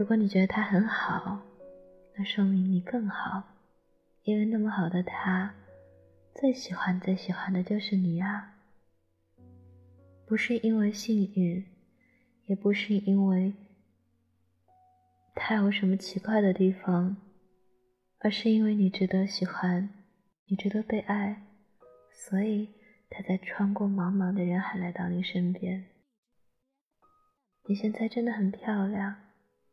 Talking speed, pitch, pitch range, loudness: 180 characters per minute, 195 Hz, 180-210 Hz, -29 LUFS